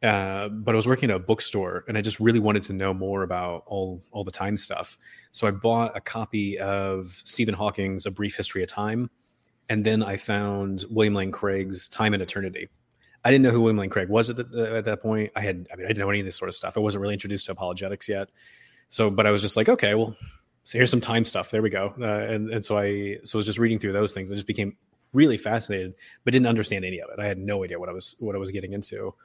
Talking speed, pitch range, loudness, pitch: 270 wpm, 100-110 Hz, -25 LUFS, 105 Hz